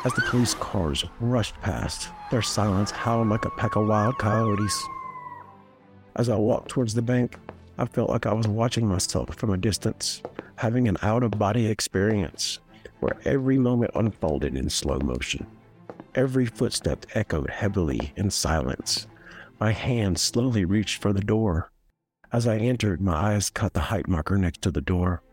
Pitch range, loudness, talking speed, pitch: 95-120 Hz, -25 LUFS, 165 wpm, 105 Hz